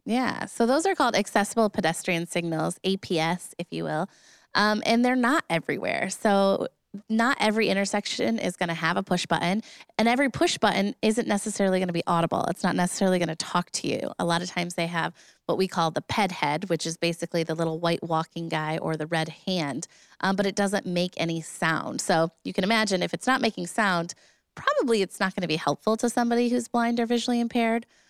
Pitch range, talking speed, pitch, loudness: 170-225 Hz, 215 wpm, 190 Hz, -26 LUFS